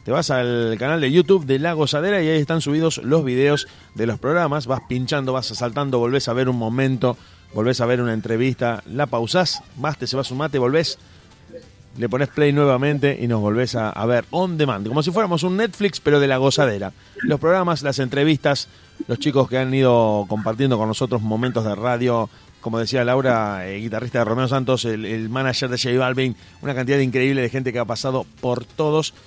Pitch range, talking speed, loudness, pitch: 115-145 Hz, 205 wpm, -20 LUFS, 130 Hz